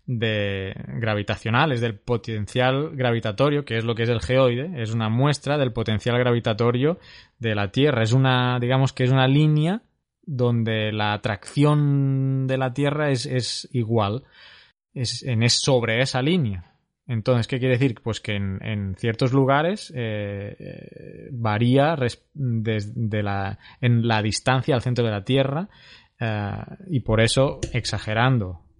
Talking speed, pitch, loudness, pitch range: 150 wpm, 120 Hz, -23 LUFS, 110-135 Hz